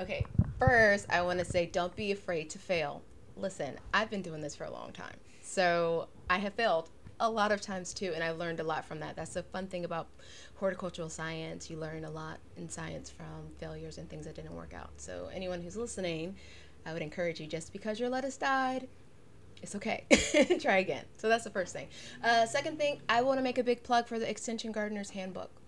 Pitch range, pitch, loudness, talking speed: 165-225 Hz, 185 Hz, -33 LUFS, 215 wpm